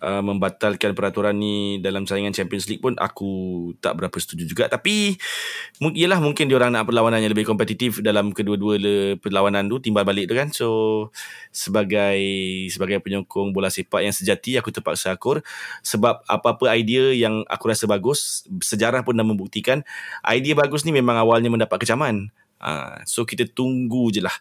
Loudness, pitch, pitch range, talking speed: -21 LUFS, 110 Hz, 100-125 Hz, 160 wpm